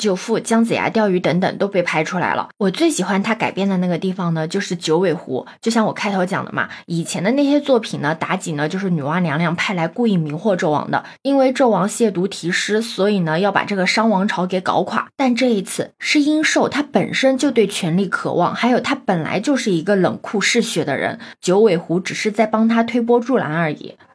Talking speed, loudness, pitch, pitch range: 330 characters per minute, -18 LUFS, 195 Hz, 175-230 Hz